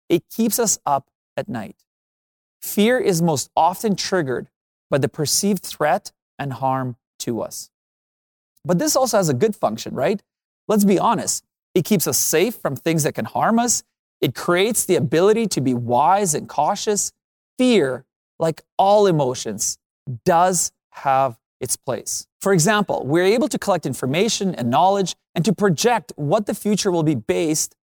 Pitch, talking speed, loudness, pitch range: 180 Hz, 160 wpm, -20 LUFS, 140-210 Hz